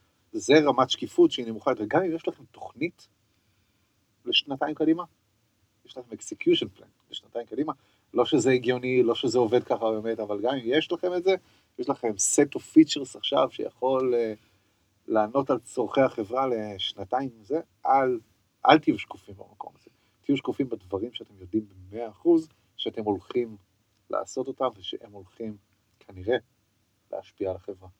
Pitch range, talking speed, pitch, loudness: 105-130 Hz, 150 wpm, 115 Hz, -26 LUFS